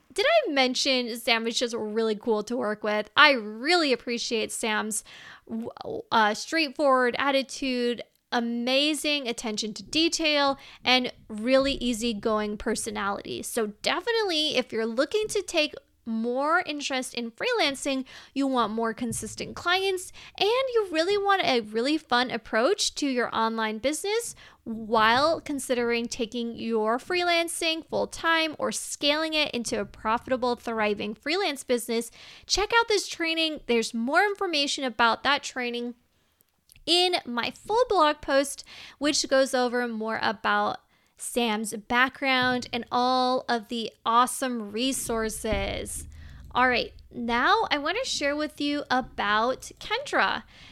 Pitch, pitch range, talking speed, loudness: 255 Hz, 230-300 Hz, 130 wpm, -26 LUFS